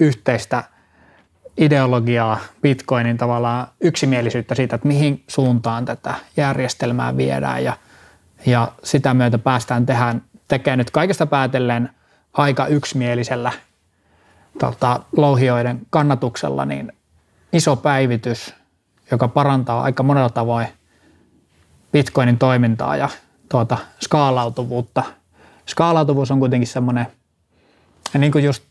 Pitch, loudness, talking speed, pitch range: 125 Hz, -18 LUFS, 95 wpm, 115-140 Hz